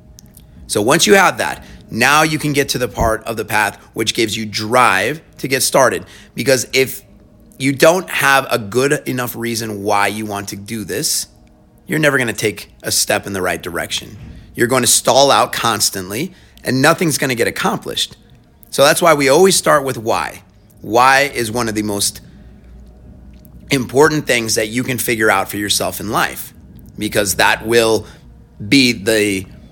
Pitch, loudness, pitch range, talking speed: 115 Hz, -15 LUFS, 100-135 Hz, 180 wpm